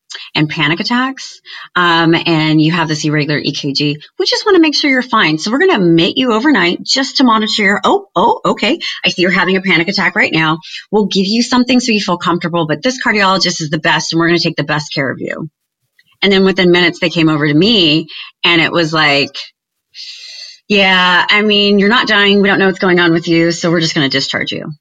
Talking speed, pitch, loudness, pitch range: 240 wpm, 175 Hz, -11 LUFS, 160-215 Hz